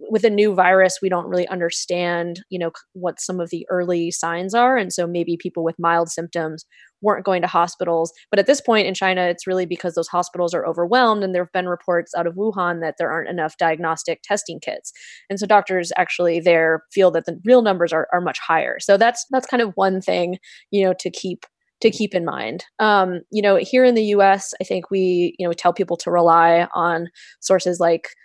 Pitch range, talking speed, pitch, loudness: 170-195 Hz, 220 wpm, 180 Hz, -19 LUFS